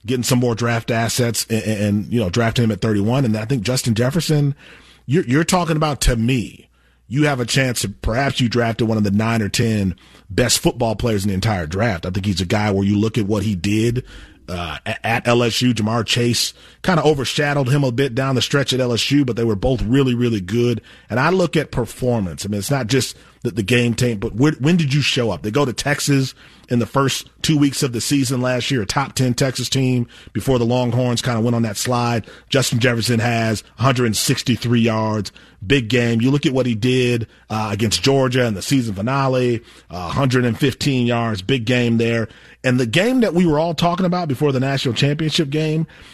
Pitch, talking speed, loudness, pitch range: 120 Hz, 215 wpm, -18 LUFS, 110-135 Hz